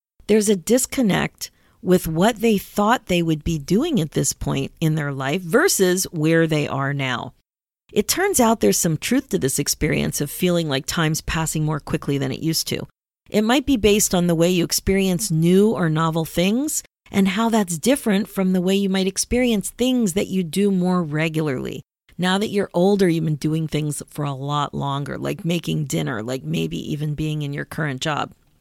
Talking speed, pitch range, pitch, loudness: 195 wpm, 155-200 Hz, 175 Hz, -20 LUFS